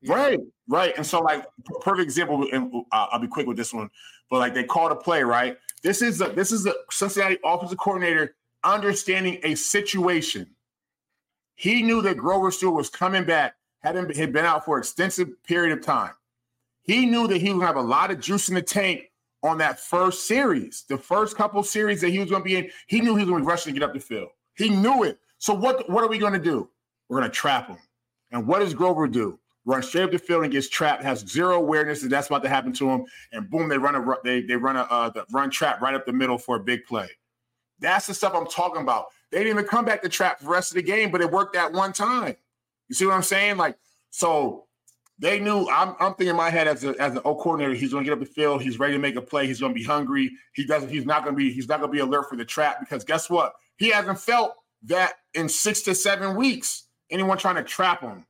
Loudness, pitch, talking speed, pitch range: -23 LUFS, 170 Hz, 255 wpm, 135-195 Hz